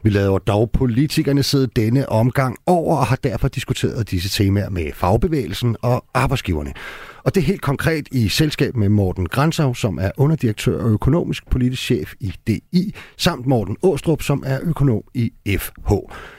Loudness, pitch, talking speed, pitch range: -19 LUFS, 125 Hz, 165 wpm, 105-140 Hz